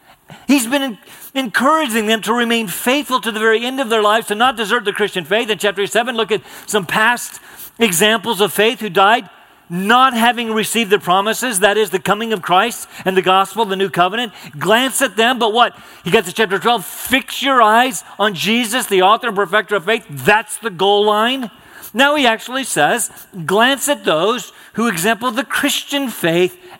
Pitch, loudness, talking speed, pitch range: 225 Hz, -15 LUFS, 195 wpm, 205-240 Hz